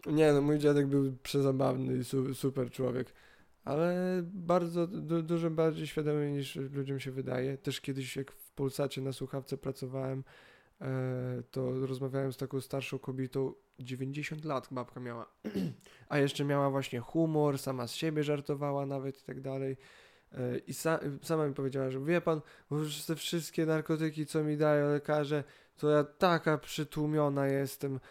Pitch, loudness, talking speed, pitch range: 140 Hz, -34 LUFS, 145 wpm, 135-150 Hz